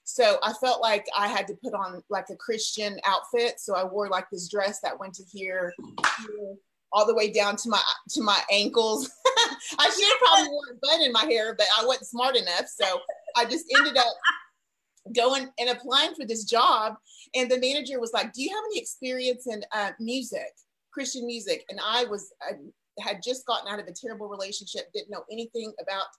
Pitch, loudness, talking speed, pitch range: 230 Hz, -25 LUFS, 205 wpm, 205-260 Hz